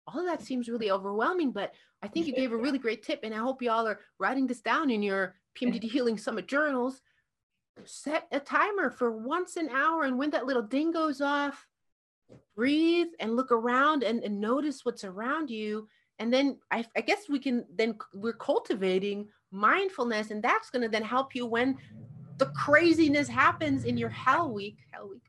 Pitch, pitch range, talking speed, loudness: 250 Hz, 220-295 Hz, 195 wpm, -29 LUFS